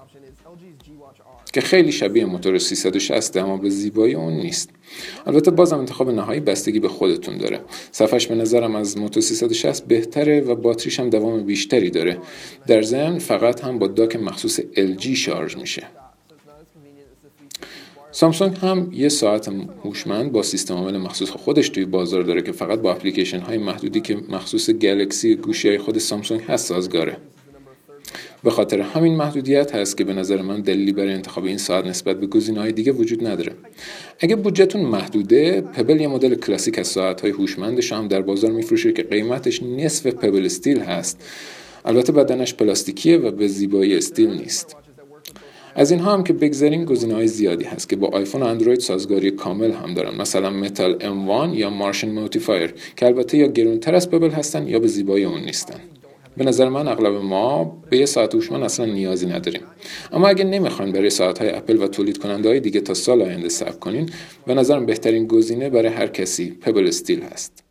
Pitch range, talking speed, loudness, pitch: 100-170 Hz, 170 wpm, -19 LUFS, 130 Hz